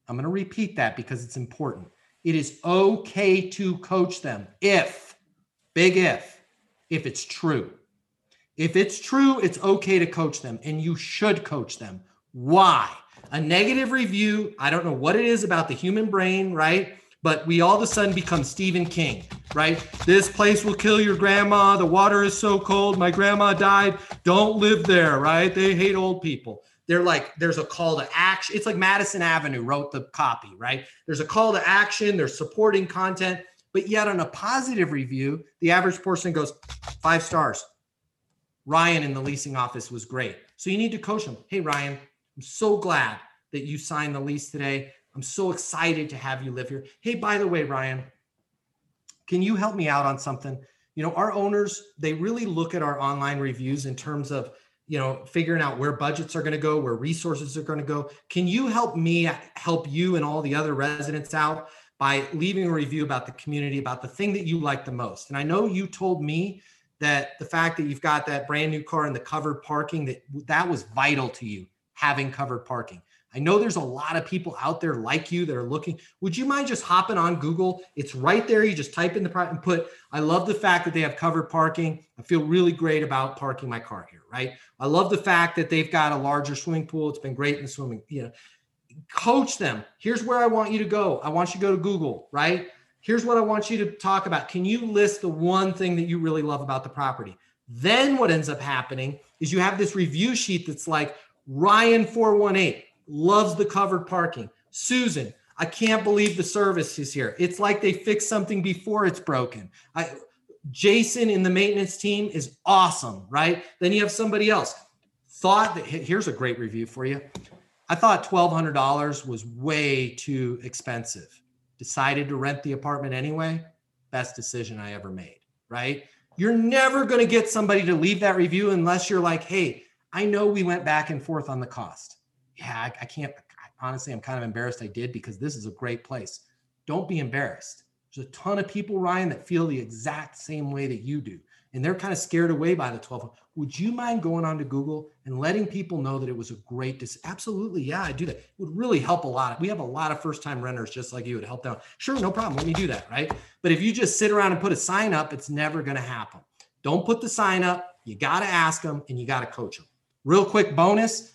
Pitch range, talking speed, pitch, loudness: 140-195 Hz, 215 wpm, 160 Hz, -24 LUFS